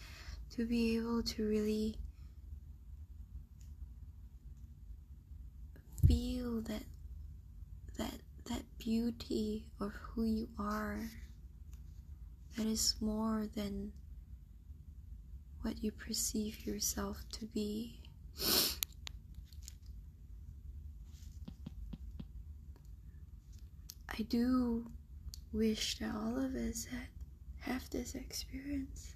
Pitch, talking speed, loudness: 80 Hz, 70 wpm, -38 LUFS